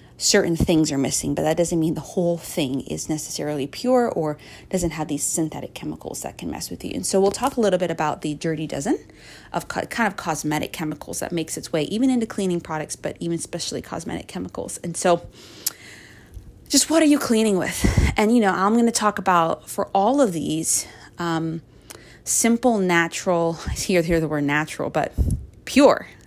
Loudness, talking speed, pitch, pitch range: -22 LUFS, 195 wpm, 170 Hz, 155-200 Hz